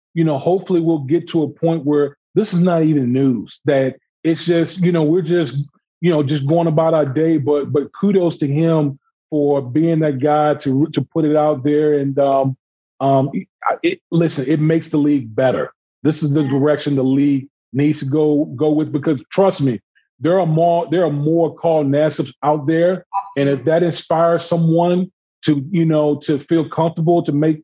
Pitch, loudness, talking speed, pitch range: 155 Hz, -17 LUFS, 195 wpm, 145-165 Hz